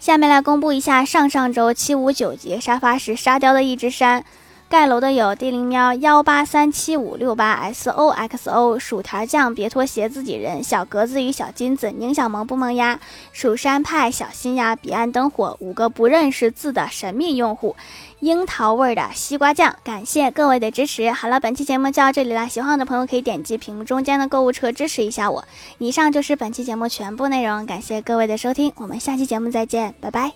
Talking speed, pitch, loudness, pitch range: 315 characters per minute, 250 Hz, -19 LUFS, 230-275 Hz